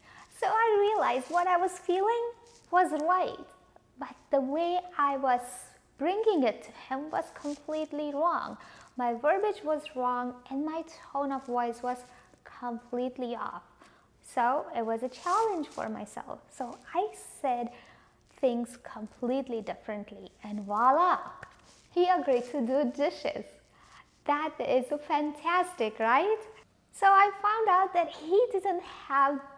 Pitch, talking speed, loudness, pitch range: 295 Hz, 130 wpm, -30 LUFS, 250-360 Hz